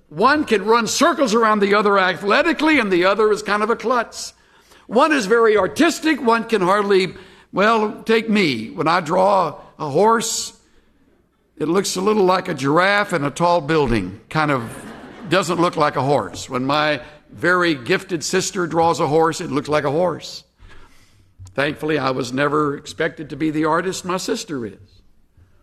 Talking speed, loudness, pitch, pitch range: 175 wpm, -18 LUFS, 180 Hz, 150-215 Hz